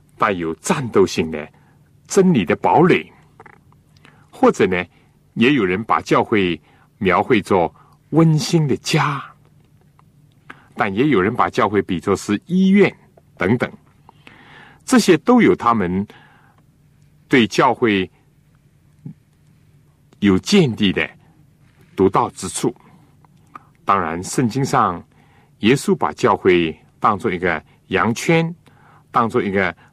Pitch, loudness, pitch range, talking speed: 145 Hz, -17 LUFS, 100-155 Hz, 155 characters per minute